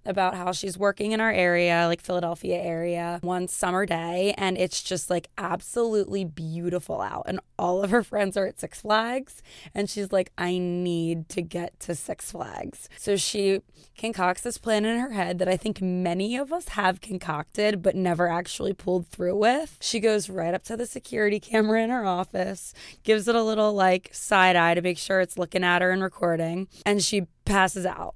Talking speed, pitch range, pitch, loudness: 195 wpm, 175-210 Hz, 185 Hz, -26 LUFS